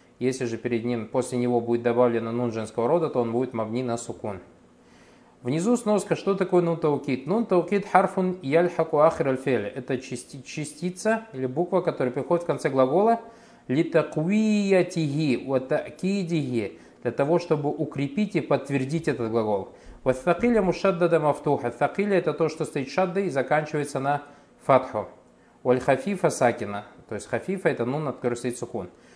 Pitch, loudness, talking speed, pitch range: 145 Hz, -25 LUFS, 135 wpm, 125-175 Hz